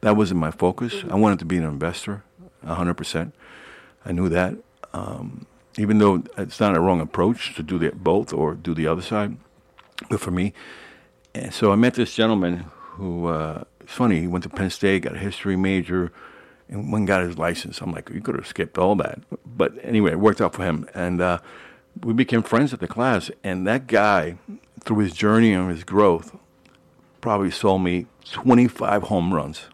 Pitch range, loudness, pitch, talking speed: 90-105 Hz, -22 LUFS, 95 Hz, 200 wpm